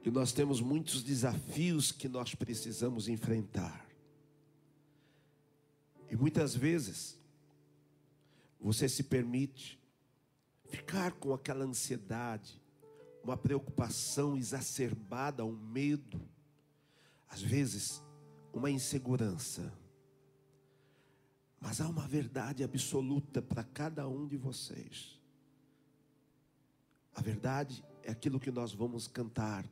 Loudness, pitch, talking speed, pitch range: -37 LUFS, 135 Hz, 95 wpm, 120-145 Hz